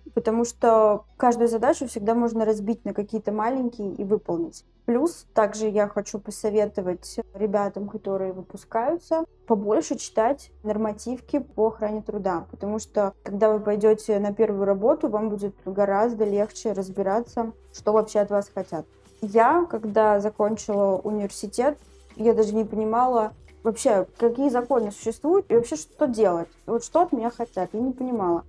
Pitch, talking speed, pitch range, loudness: 220 Hz, 145 wpm, 205-235 Hz, -24 LUFS